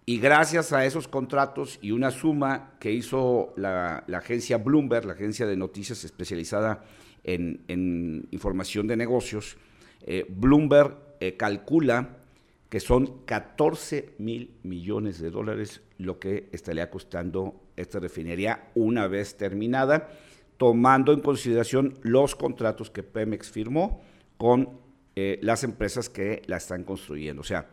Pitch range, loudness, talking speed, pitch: 95-130 Hz, -26 LUFS, 135 wpm, 110 Hz